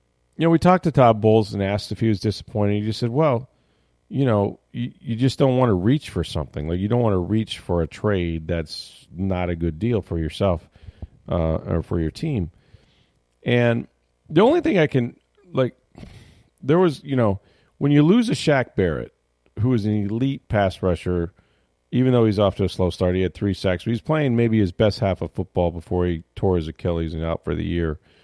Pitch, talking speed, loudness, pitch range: 100 Hz, 220 wpm, -22 LUFS, 85-120 Hz